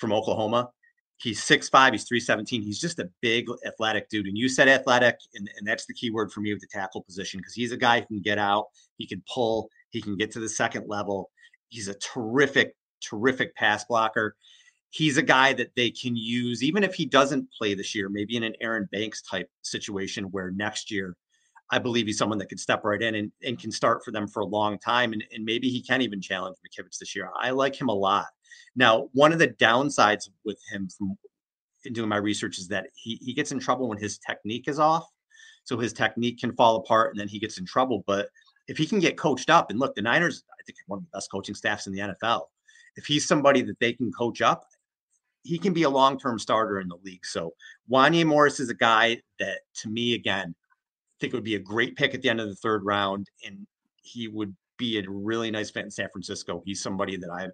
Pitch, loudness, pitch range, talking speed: 110 Hz, -25 LUFS, 100-125 Hz, 235 wpm